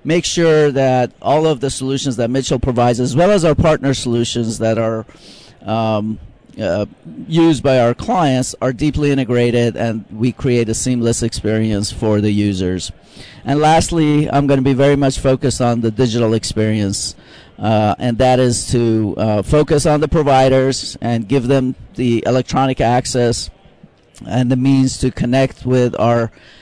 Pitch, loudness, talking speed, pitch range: 125 Hz, -15 LUFS, 160 wpm, 115-135 Hz